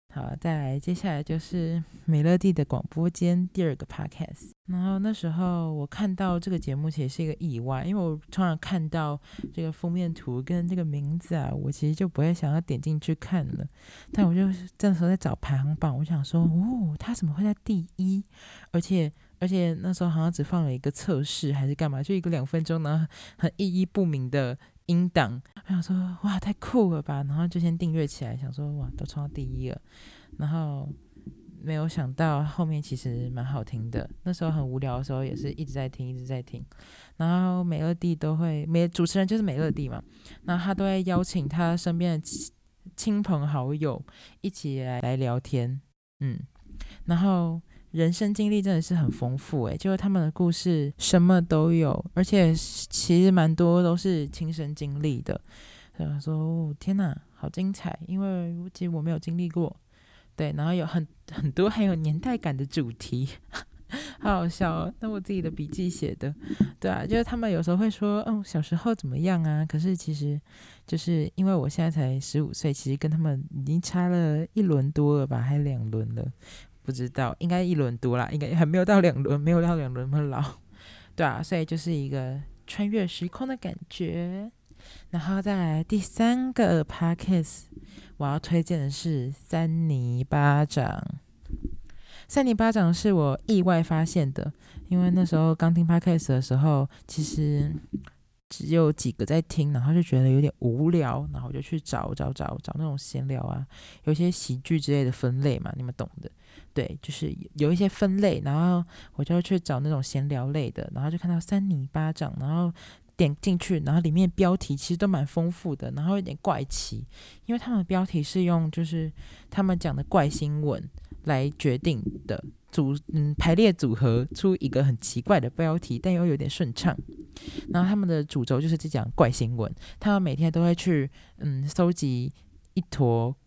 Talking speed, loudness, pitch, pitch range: 280 characters per minute, -27 LUFS, 160 Hz, 145-175 Hz